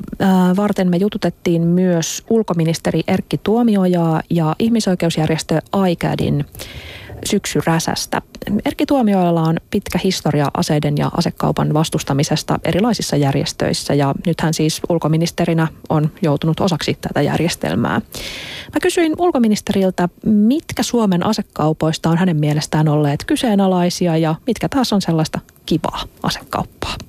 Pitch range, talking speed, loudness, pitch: 155-205 Hz, 110 wpm, -17 LUFS, 175 Hz